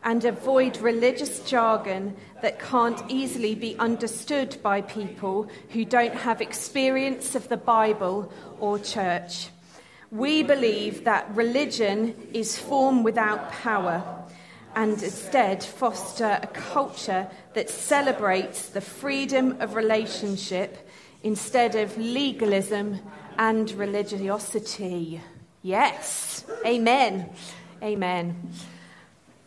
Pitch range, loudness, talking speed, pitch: 195-240 Hz, -25 LUFS, 95 wpm, 220 Hz